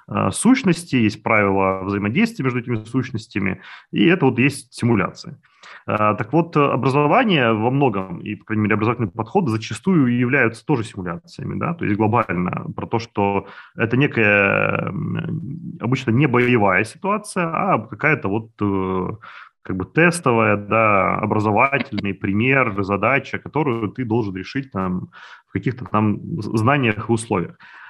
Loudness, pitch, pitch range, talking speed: -19 LUFS, 115 Hz, 105-140 Hz, 130 wpm